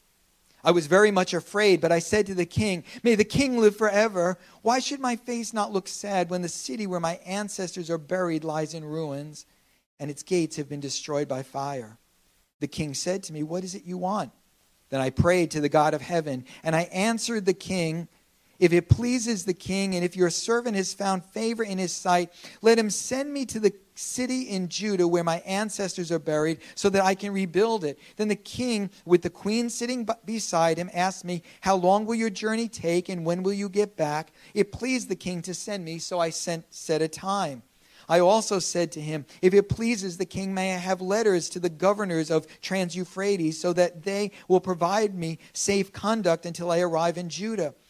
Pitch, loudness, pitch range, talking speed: 185 Hz, -26 LUFS, 165-205 Hz, 210 wpm